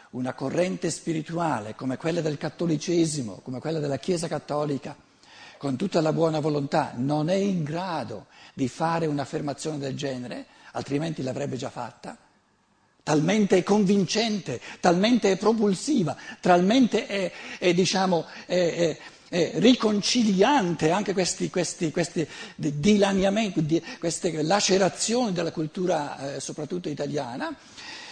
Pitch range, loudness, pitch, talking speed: 150-195 Hz, -25 LUFS, 170 Hz, 120 wpm